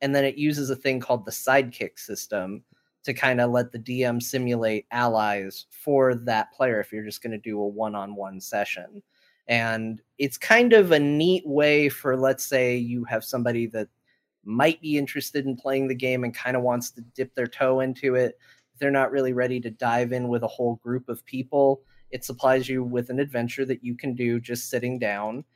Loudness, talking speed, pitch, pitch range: -25 LUFS, 210 wpm, 125 Hz, 120-135 Hz